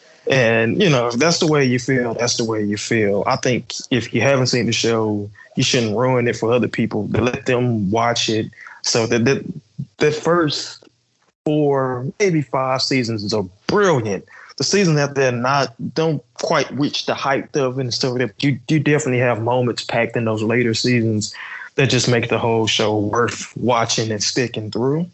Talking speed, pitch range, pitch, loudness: 190 wpm, 115-140 Hz, 125 Hz, -18 LUFS